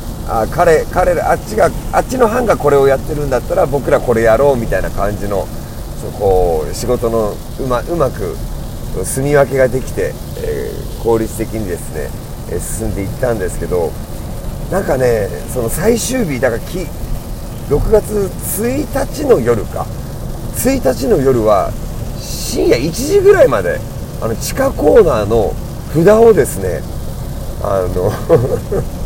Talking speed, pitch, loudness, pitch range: 260 characters per minute, 125 Hz, -15 LUFS, 110-145 Hz